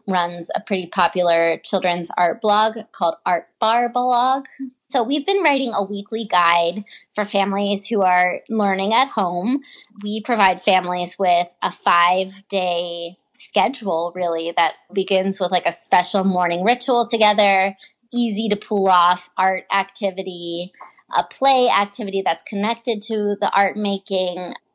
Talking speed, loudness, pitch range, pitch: 140 wpm, -19 LUFS, 180-225 Hz, 195 Hz